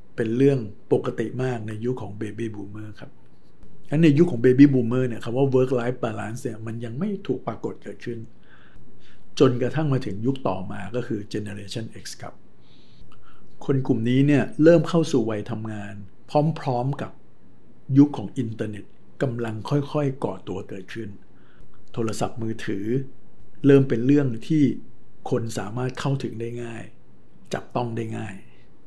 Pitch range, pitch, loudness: 110-135 Hz, 120 Hz, -24 LUFS